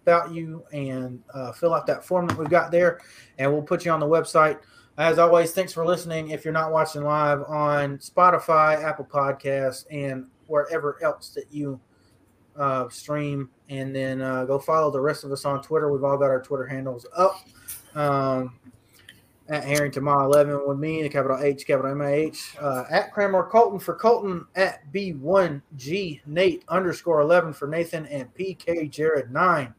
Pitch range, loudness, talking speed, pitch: 135-165 Hz, -23 LUFS, 175 wpm, 150 Hz